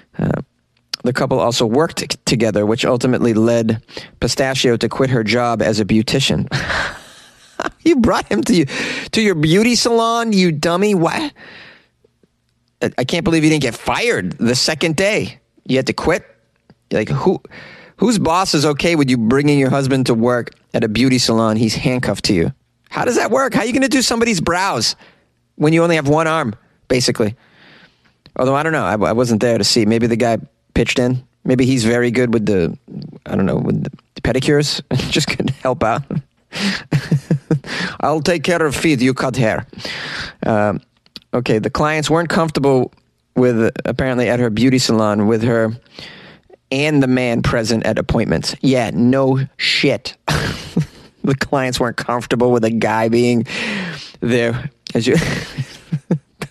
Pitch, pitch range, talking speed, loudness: 130 Hz, 115-160 Hz, 170 wpm, -16 LUFS